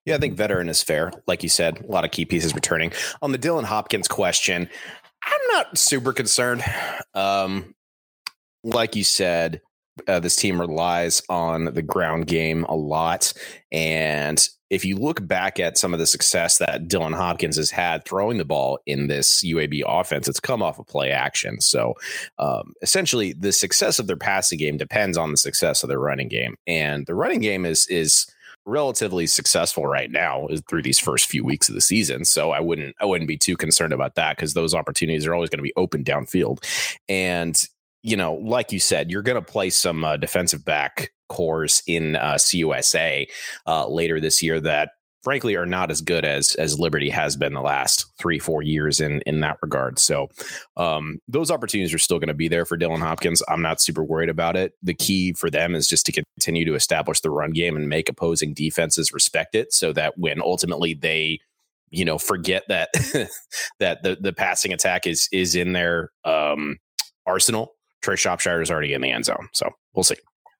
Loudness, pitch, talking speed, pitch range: -21 LUFS, 80 Hz, 200 wpm, 80-90 Hz